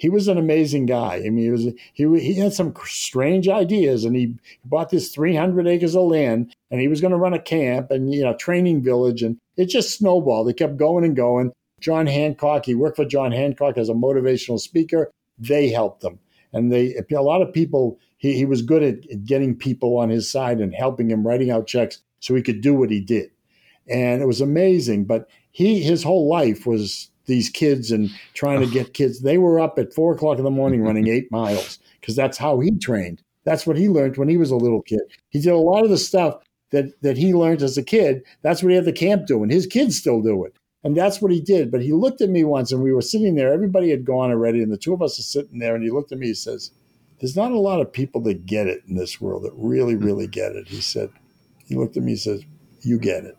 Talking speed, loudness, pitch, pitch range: 245 wpm, -20 LUFS, 135 Hz, 120-165 Hz